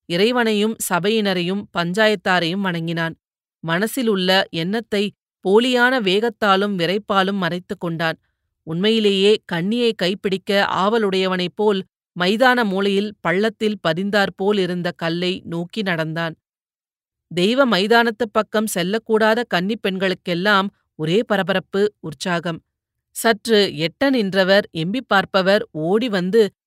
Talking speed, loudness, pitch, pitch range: 90 wpm, -19 LUFS, 195 Hz, 175-215 Hz